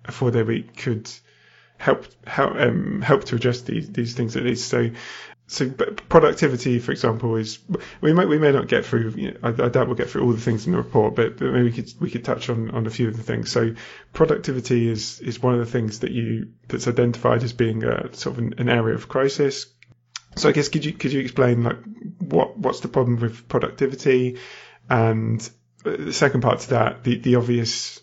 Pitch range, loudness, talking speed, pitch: 115-130 Hz, -22 LUFS, 220 wpm, 120 Hz